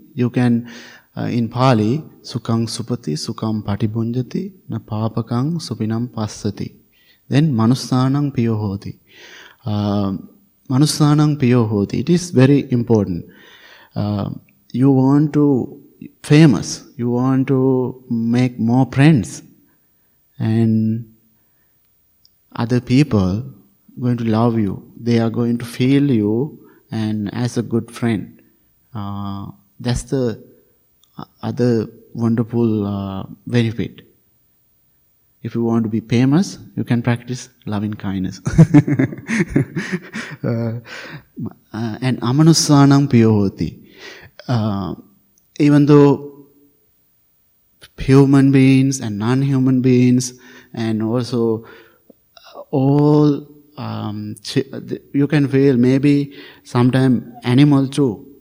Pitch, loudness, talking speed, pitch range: 120 Hz, -17 LUFS, 90 wpm, 110-140 Hz